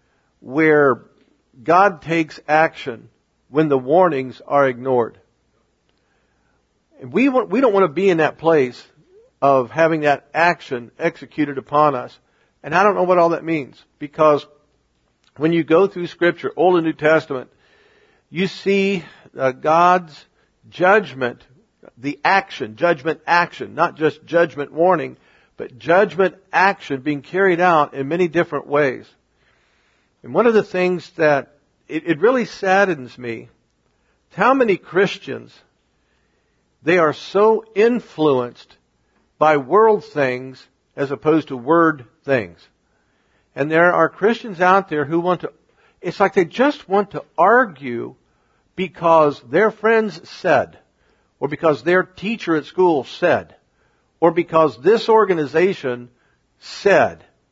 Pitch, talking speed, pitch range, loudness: 160 Hz, 130 wpm, 145-185 Hz, -18 LUFS